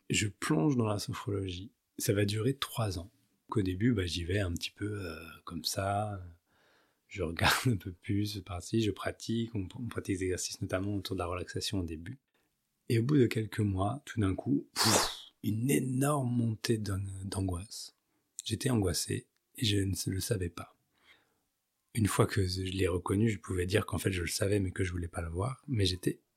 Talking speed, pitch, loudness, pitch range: 205 wpm, 100 Hz, -33 LUFS, 95-115 Hz